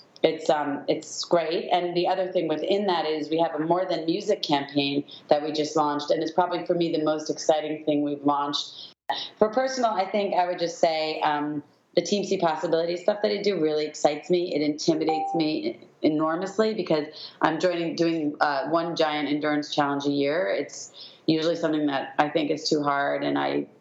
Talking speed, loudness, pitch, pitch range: 200 wpm, -25 LUFS, 160 Hz, 150-175 Hz